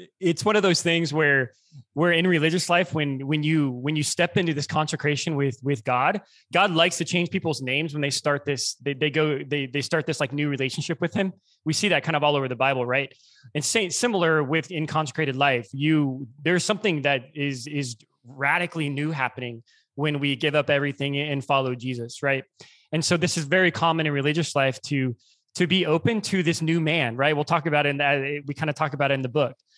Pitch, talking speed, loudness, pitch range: 150 Hz, 225 wpm, -24 LUFS, 140-165 Hz